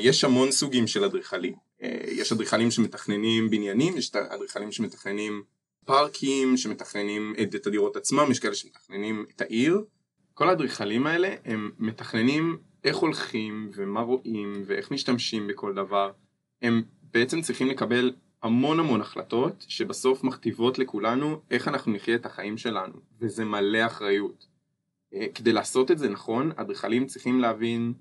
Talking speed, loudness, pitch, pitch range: 135 wpm, -27 LUFS, 115 Hz, 105-130 Hz